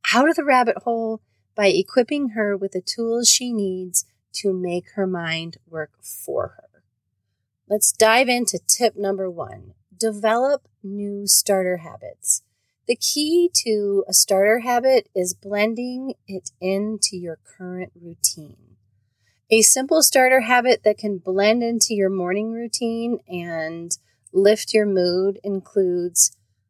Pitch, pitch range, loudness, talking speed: 195 Hz, 170-230 Hz, -20 LUFS, 135 wpm